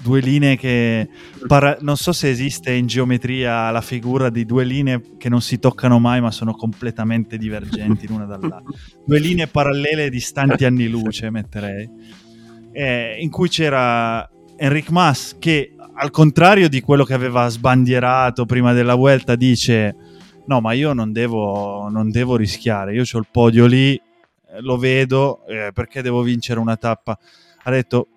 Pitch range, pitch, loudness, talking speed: 115-135 Hz, 125 Hz, -17 LUFS, 160 wpm